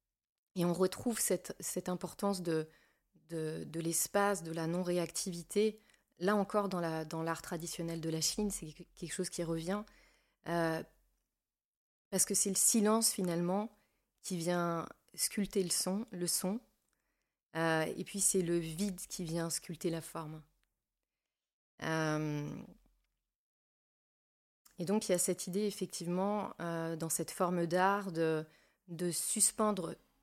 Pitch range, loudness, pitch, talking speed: 165-195 Hz, -35 LUFS, 175 Hz, 140 wpm